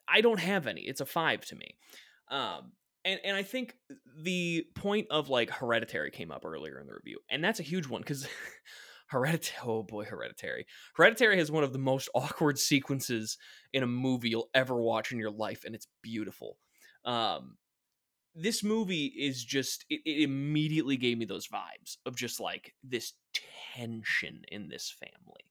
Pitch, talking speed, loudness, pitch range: 140 Hz, 175 wpm, -32 LUFS, 120-185 Hz